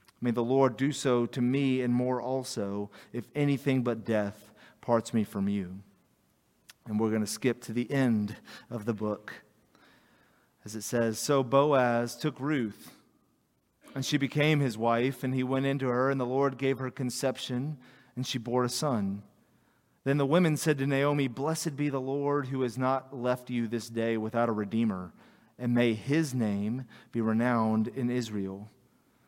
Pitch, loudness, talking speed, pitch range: 125 Hz, -30 LUFS, 175 wpm, 115-135 Hz